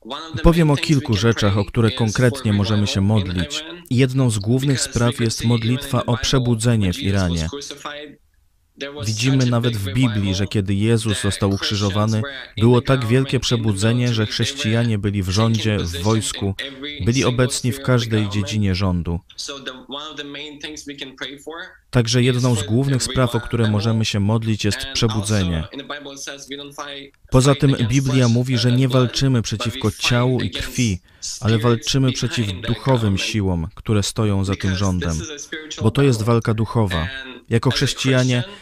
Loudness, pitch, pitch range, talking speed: -19 LUFS, 115 Hz, 105-130 Hz, 135 wpm